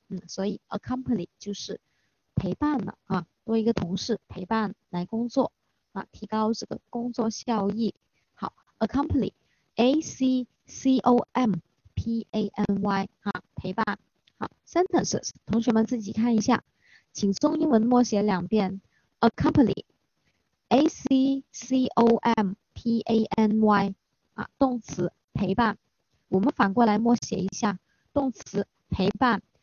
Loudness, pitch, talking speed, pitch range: -26 LUFS, 225 Hz, 245 characters per minute, 200-245 Hz